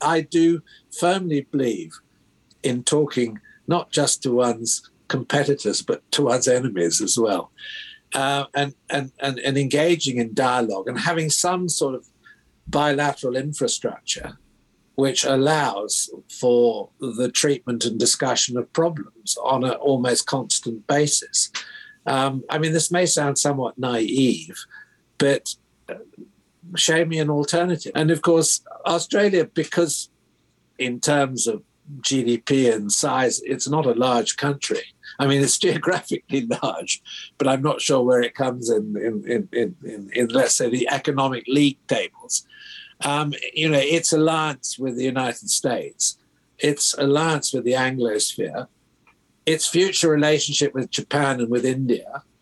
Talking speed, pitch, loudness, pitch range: 140 wpm, 140 Hz, -21 LUFS, 125-160 Hz